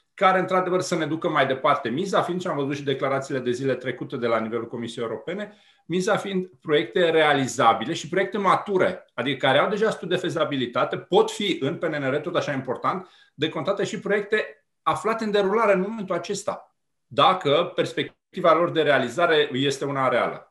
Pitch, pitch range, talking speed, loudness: 175 Hz, 140-200 Hz, 180 wpm, -23 LUFS